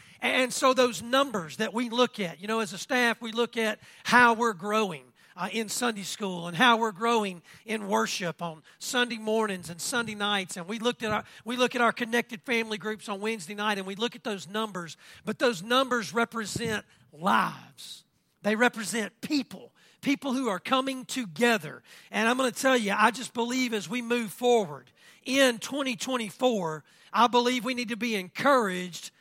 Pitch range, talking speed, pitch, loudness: 200-245 Hz, 185 wpm, 225 Hz, -27 LUFS